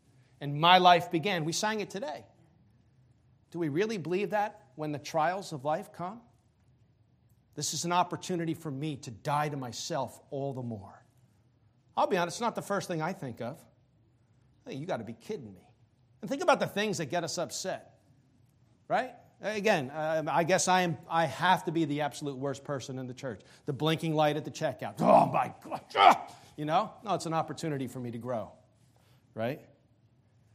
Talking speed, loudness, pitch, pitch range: 190 wpm, -30 LUFS, 145 Hz, 125-170 Hz